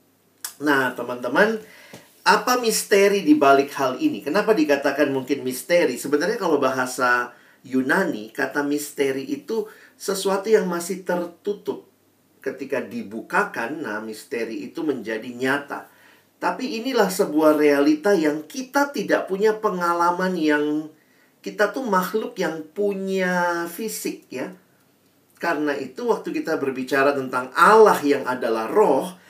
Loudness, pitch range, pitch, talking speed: -22 LUFS, 145-215 Hz, 175 Hz, 115 wpm